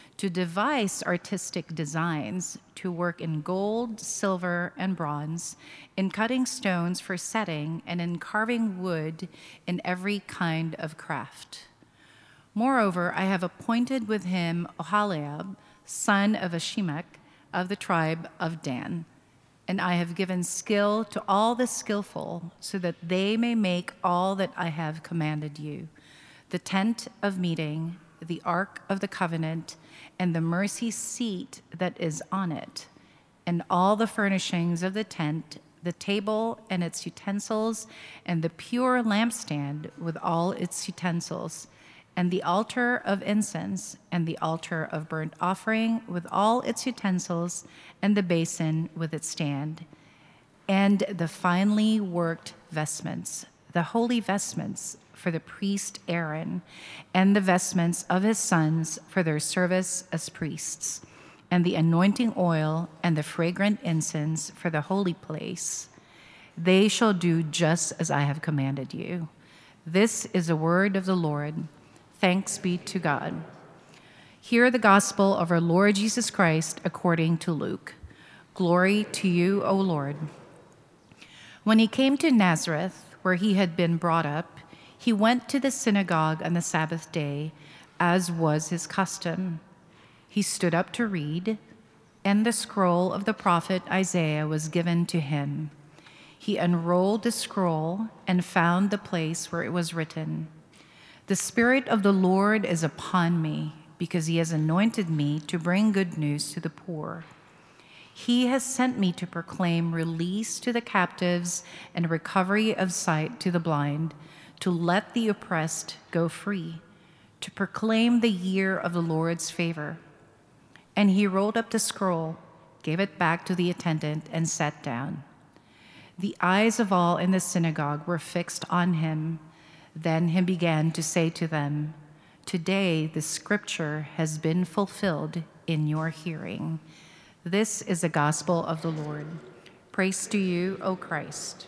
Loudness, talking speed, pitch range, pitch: -27 LUFS, 145 wpm, 160-195 Hz, 175 Hz